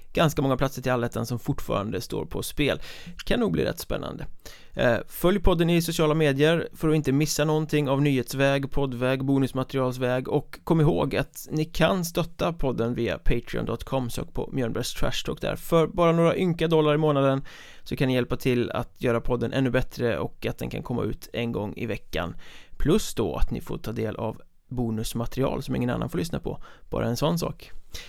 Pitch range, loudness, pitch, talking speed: 125-155 Hz, -26 LUFS, 135 Hz, 195 wpm